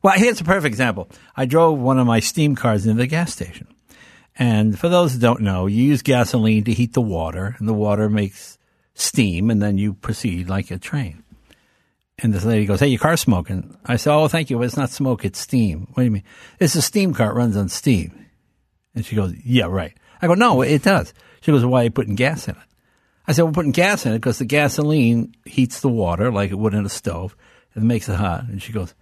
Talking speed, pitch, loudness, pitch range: 245 wpm, 120 Hz, -19 LUFS, 105-135 Hz